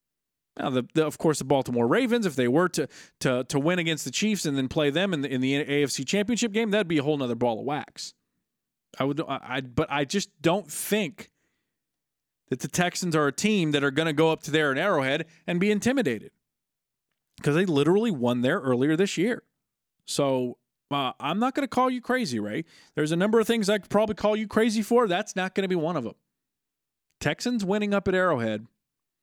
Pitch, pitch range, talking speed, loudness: 160 Hz, 140-205 Hz, 220 wpm, -26 LUFS